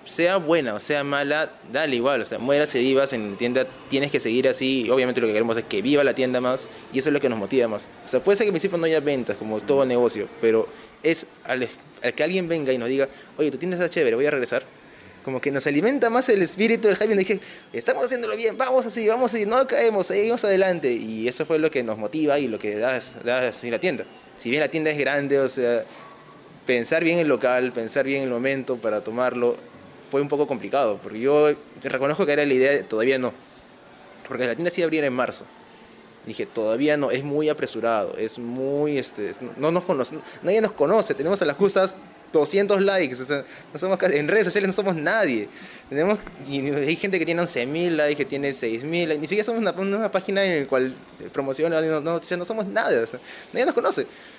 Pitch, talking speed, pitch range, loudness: 145 Hz, 235 wpm, 130-185 Hz, -23 LUFS